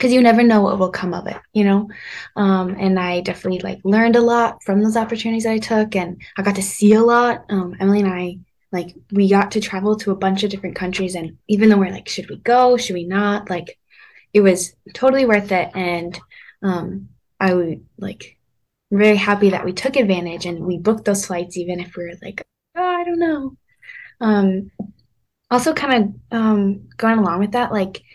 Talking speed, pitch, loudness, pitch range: 210 wpm, 200 Hz, -18 LUFS, 185-225 Hz